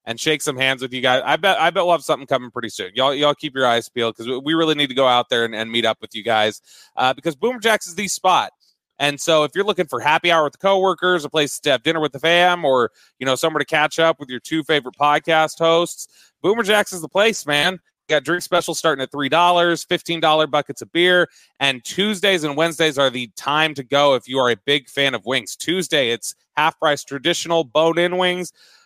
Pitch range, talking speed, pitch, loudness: 135-170 Hz, 250 wpm, 155 Hz, -18 LUFS